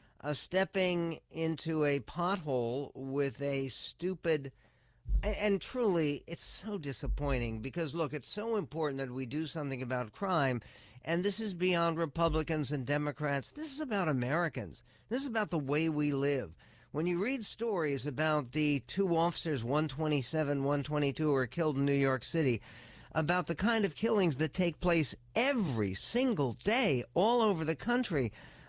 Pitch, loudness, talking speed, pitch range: 155 Hz, -34 LUFS, 155 wpm, 140-180 Hz